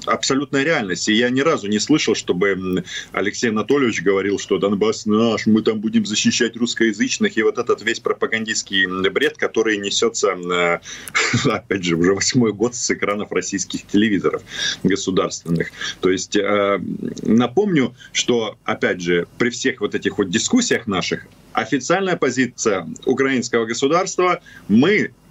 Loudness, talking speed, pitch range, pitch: -19 LUFS, 135 wpm, 100-135 Hz, 110 Hz